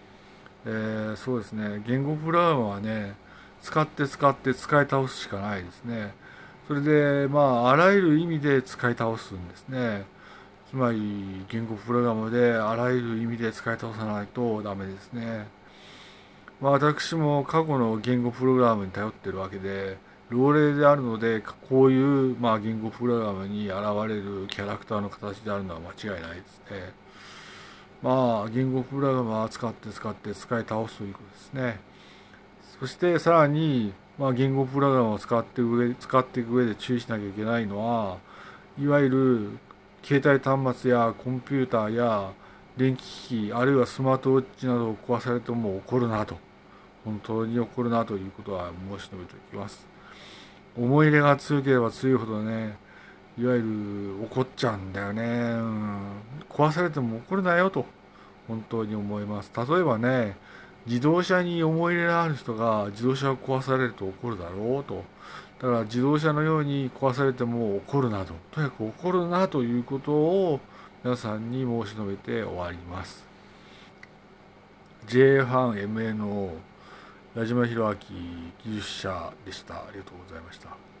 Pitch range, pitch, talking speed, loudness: 105-135 Hz, 120 Hz, 320 characters per minute, -26 LUFS